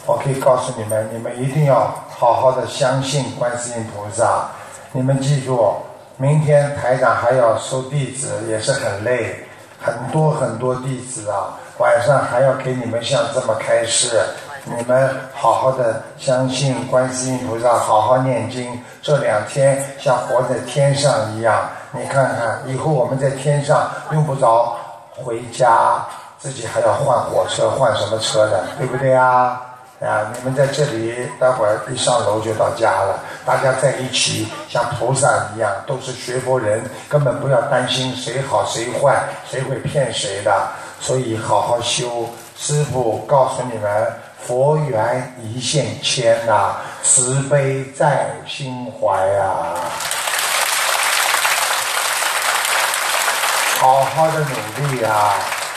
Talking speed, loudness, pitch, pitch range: 205 characters per minute, -17 LUFS, 130 Hz, 120-135 Hz